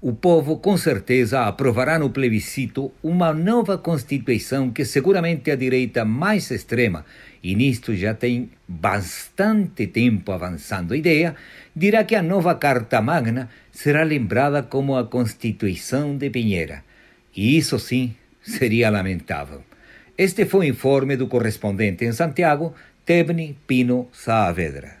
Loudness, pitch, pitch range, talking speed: -21 LUFS, 130 Hz, 110-160 Hz, 130 wpm